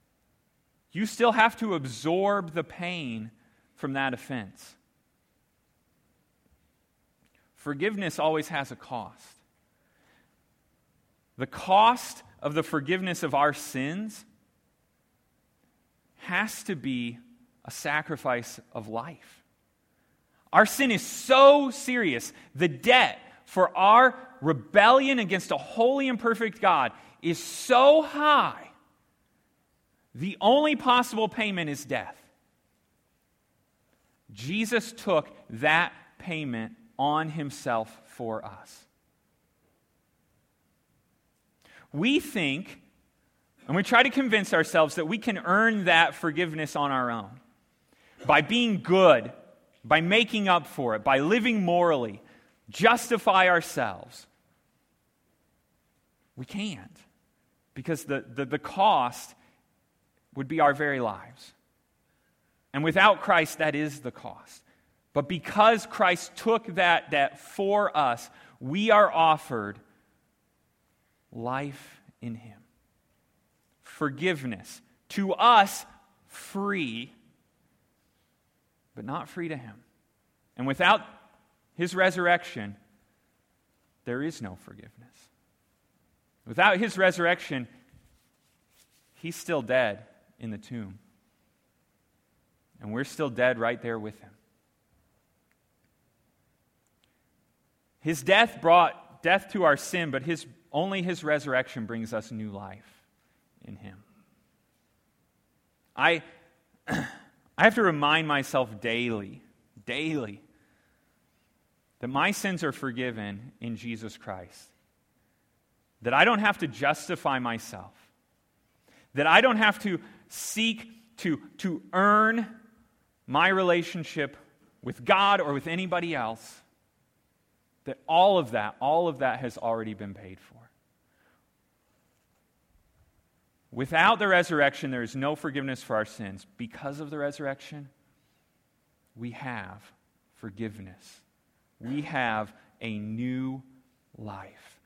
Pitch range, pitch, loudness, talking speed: 120-195 Hz, 150 Hz, -25 LUFS, 105 wpm